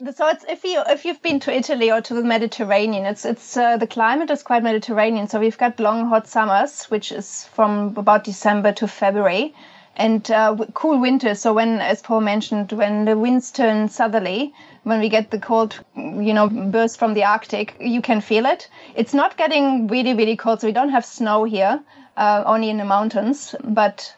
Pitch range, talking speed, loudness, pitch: 210-245 Hz, 200 wpm, -19 LUFS, 225 Hz